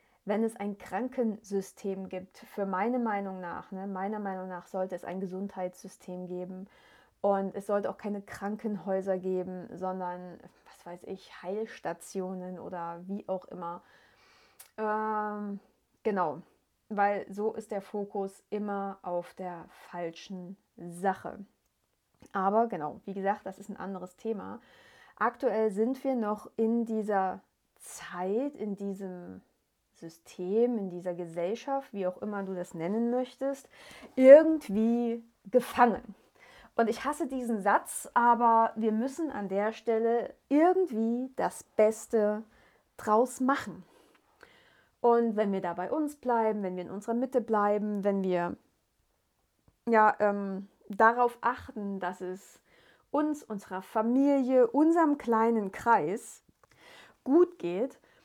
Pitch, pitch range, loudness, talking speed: 205 Hz, 185-230 Hz, -30 LUFS, 125 wpm